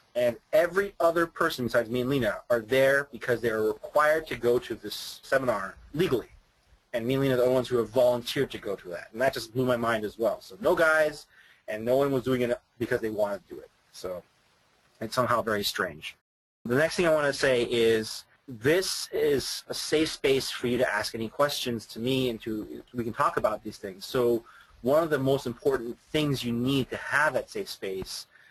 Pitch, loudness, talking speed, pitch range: 125 Hz, -27 LUFS, 225 wpm, 115-145 Hz